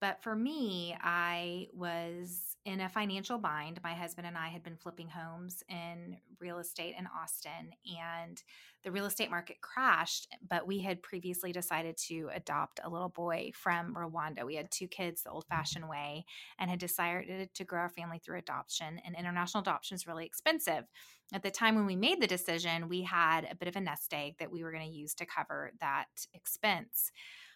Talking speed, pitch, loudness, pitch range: 195 wpm, 175 Hz, -37 LUFS, 165-185 Hz